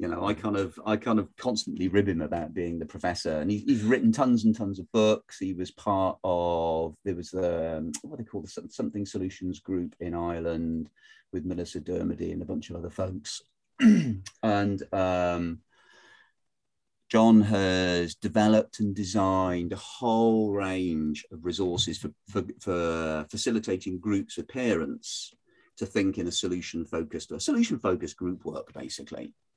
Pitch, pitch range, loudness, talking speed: 95 Hz, 85-105 Hz, -28 LUFS, 160 wpm